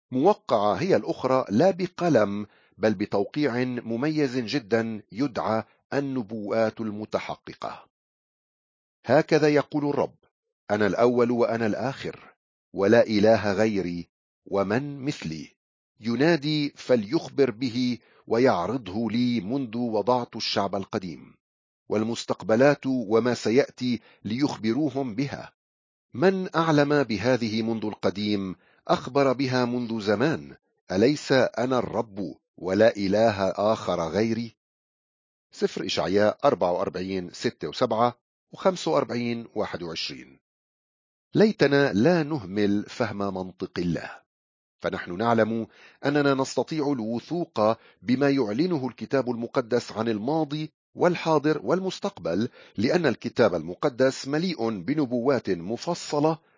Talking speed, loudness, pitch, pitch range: 90 wpm, -25 LUFS, 120 Hz, 105-145 Hz